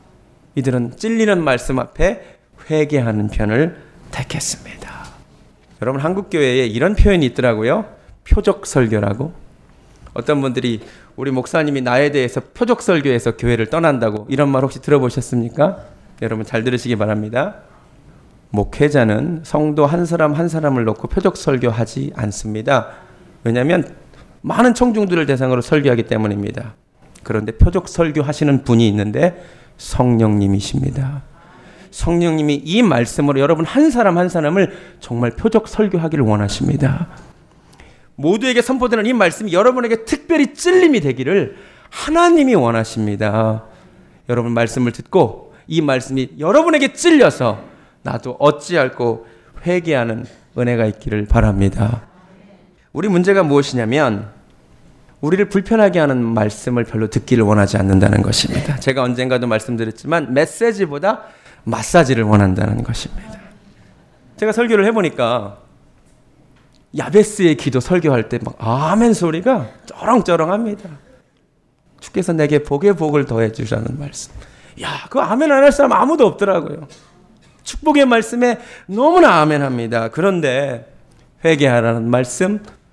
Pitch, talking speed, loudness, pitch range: 145 Hz, 315 characters per minute, -16 LUFS, 120-185 Hz